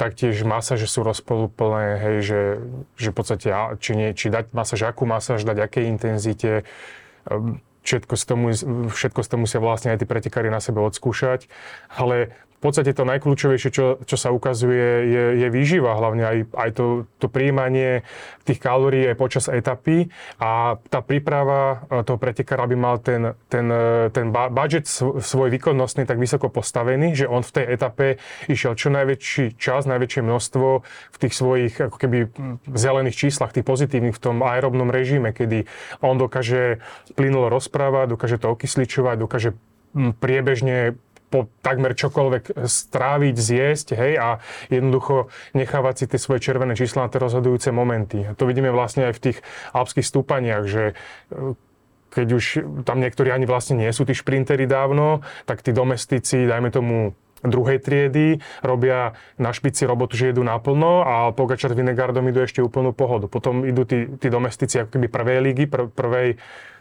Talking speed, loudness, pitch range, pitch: 160 wpm, -21 LUFS, 120-135 Hz, 125 Hz